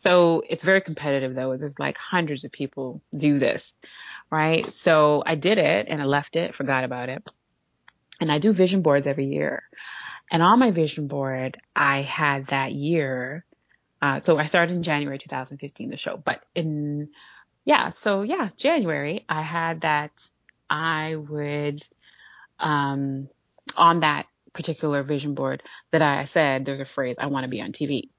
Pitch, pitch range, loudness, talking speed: 150 Hz, 140-165 Hz, -24 LUFS, 165 wpm